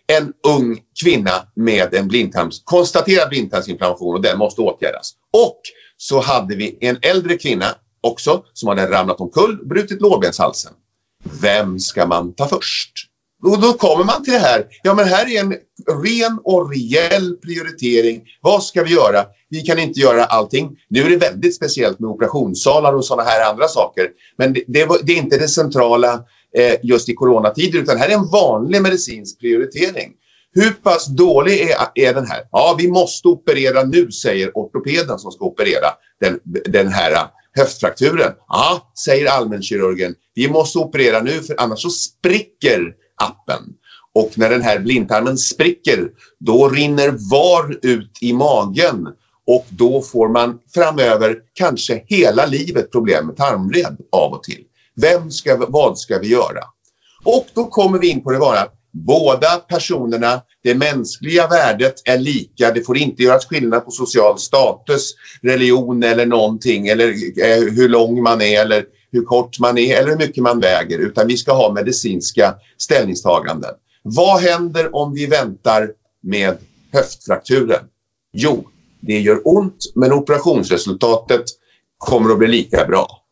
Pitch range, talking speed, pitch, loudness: 115-175 Hz, 155 wpm, 130 Hz, -15 LUFS